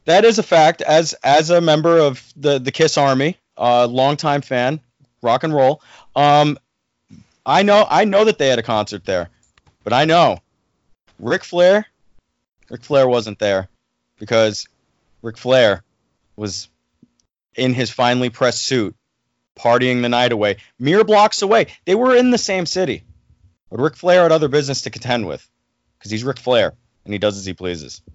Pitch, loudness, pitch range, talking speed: 125 Hz, -16 LUFS, 110-155 Hz, 175 wpm